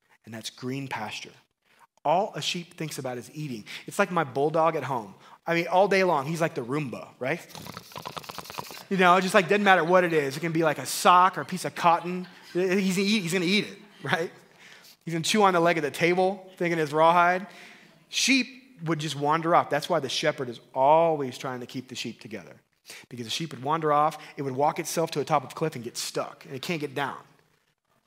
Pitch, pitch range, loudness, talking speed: 165 Hz, 145-180 Hz, -25 LUFS, 230 wpm